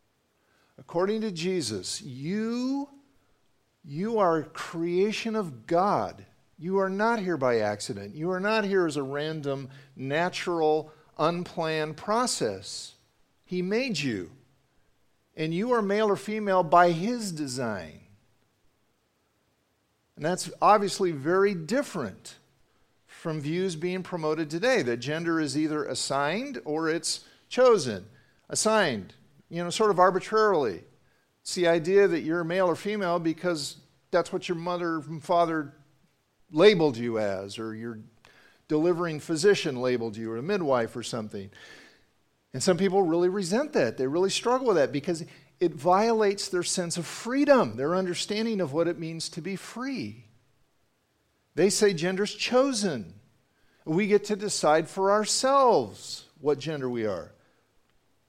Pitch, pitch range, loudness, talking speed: 175 Hz, 150-200 Hz, -27 LUFS, 135 wpm